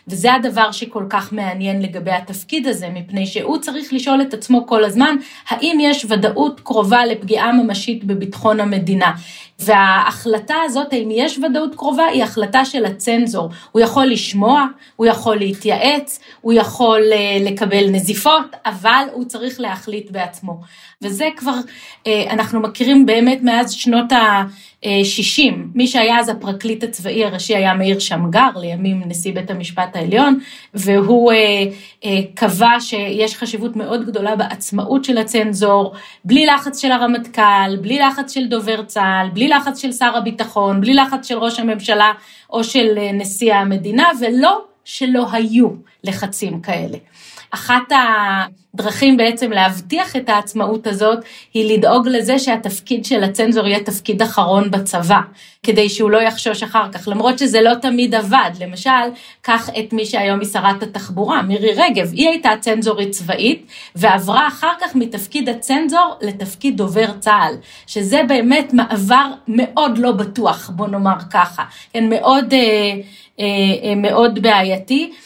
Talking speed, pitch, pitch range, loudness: 140 wpm, 220 Hz, 200-250 Hz, -15 LUFS